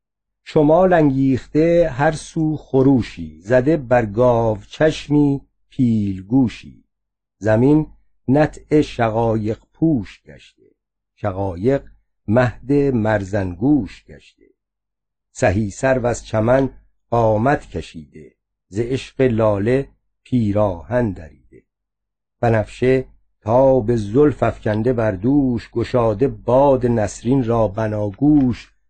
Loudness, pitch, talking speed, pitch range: -18 LUFS, 120 Hz, 85 wpm, 110-135 Hz